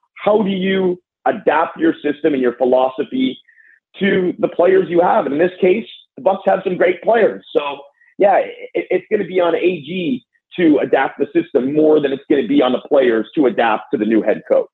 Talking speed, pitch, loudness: 210 wpm, 190 Hz, -16 LUFS